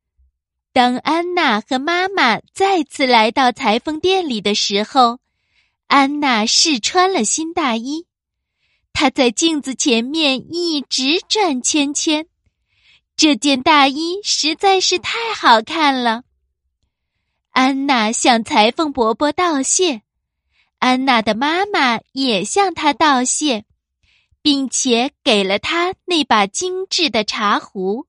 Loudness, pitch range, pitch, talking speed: -16 LUFS, 230-325 Hz, 275 Hz, 165 characters per minute